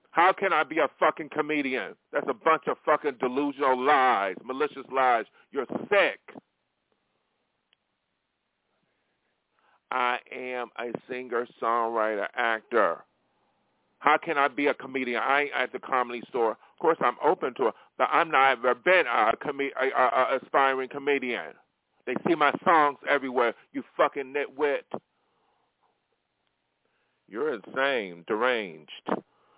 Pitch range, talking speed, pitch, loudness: 125-150 Hz, 130 wpm, 140 Hz, -26 LUFS